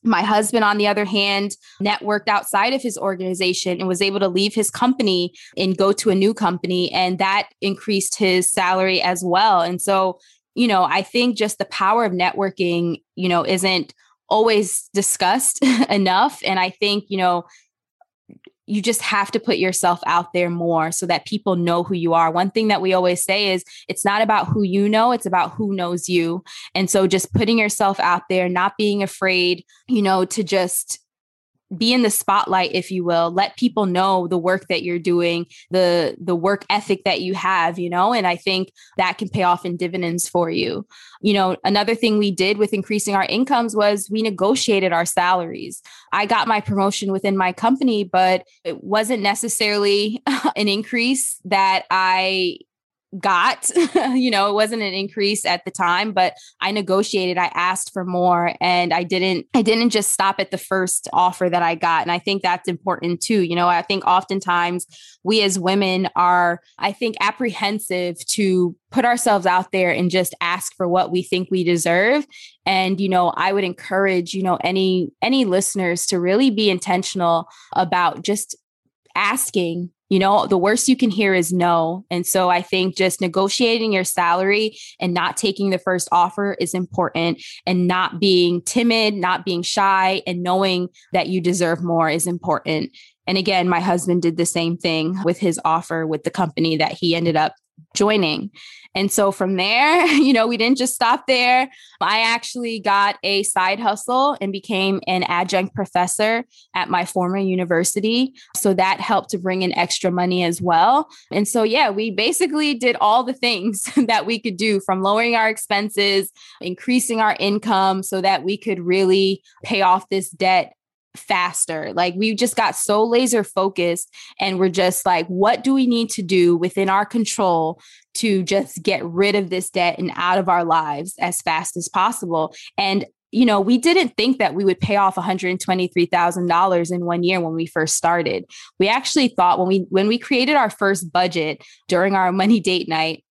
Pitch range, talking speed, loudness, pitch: 180-210 Hz, 185 wpm, -19 LUFS, 190 Hz